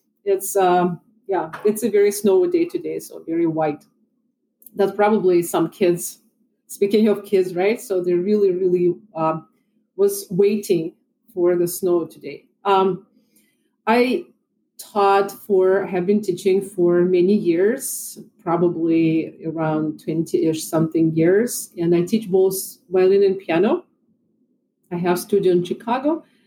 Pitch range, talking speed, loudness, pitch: 175-225 Hz, 130 wpm, -20 LUFS, 195 Hz